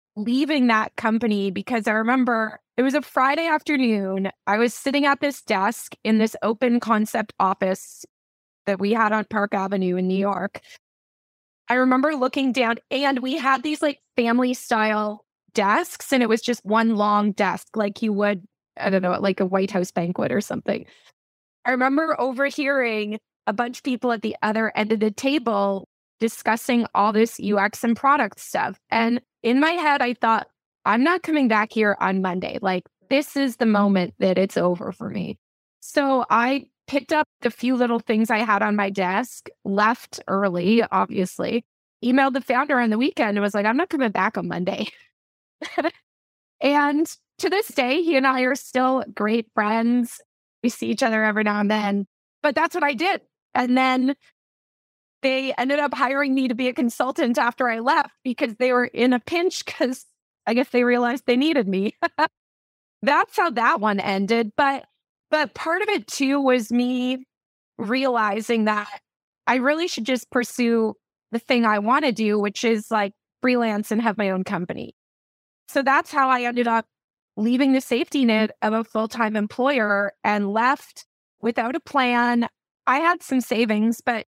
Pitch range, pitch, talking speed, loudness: 215-270 Hz, 240 Hz, 175 wpm, -22 LUFS